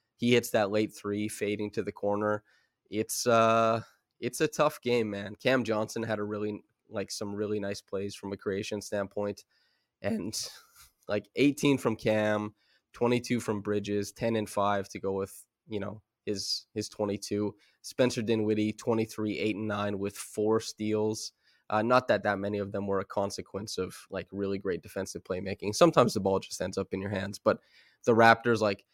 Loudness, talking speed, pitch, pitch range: -30 LUFS, 180 wpm, 105 Hz, 100-115 Hz